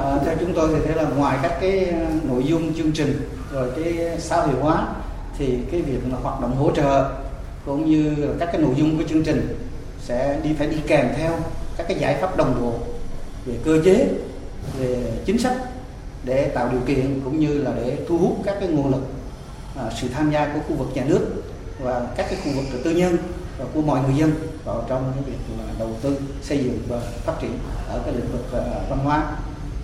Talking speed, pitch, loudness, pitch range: 215 wpm, 140 Hz, -22 LUFS, 125-155 Hz